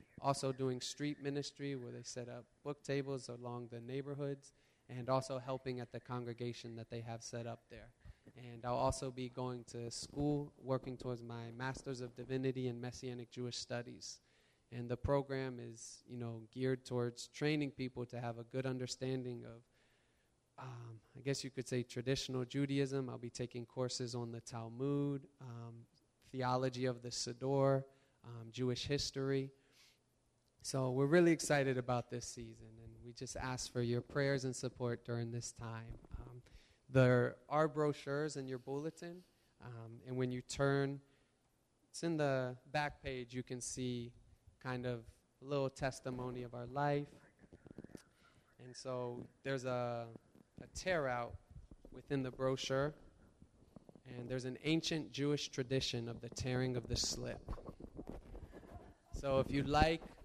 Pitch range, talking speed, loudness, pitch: 120-135 Hz, 155 wpm, -41 LUFS, 125 Hz